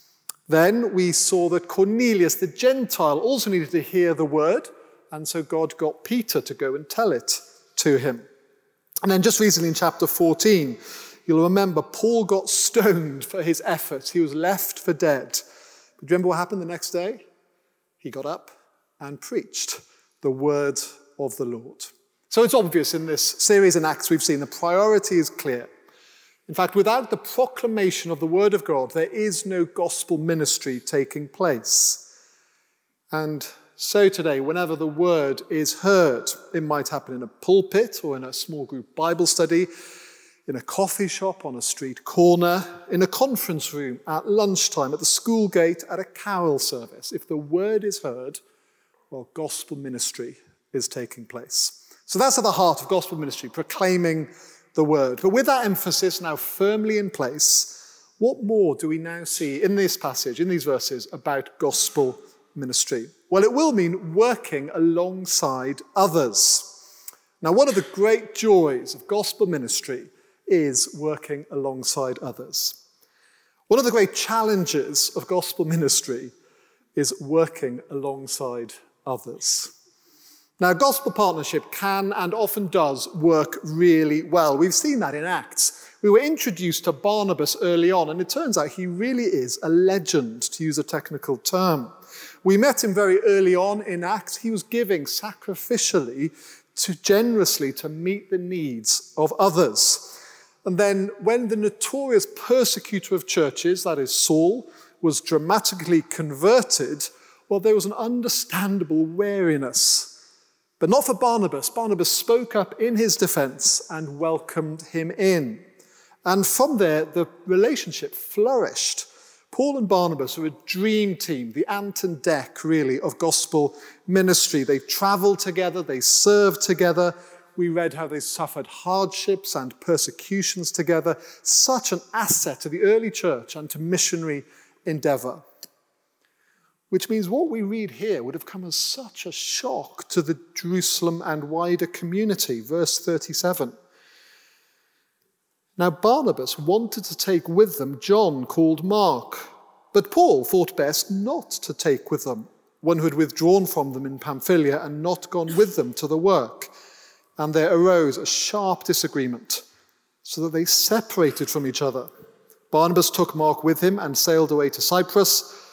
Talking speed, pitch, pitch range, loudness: 155 wpm, 180 Hz, 160-210 Hz, -22 LUFS